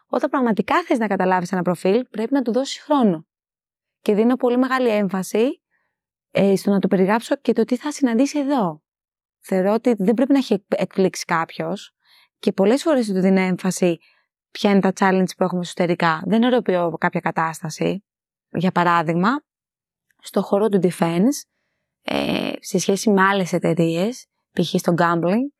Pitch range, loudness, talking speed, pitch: 180-245 Hz, -20 LUFS, 160 wpm, 195 Hz